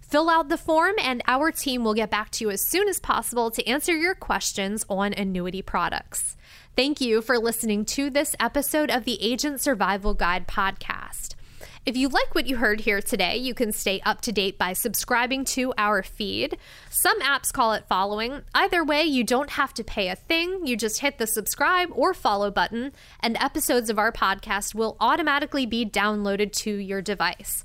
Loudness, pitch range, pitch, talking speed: -24 LUFS, 205-280 Hz, 235 Hz, 195 wpm